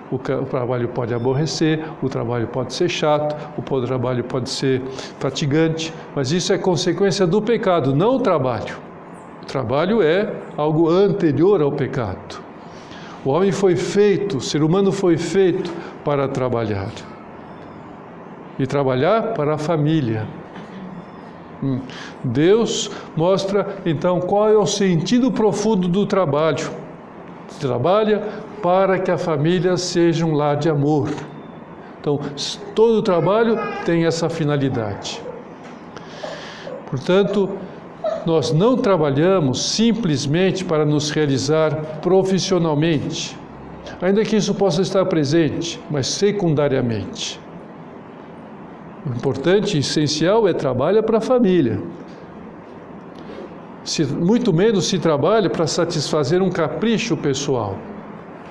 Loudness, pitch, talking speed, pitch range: -19 LUFS, 165 Hz, 115 wpm, 145-195 Hz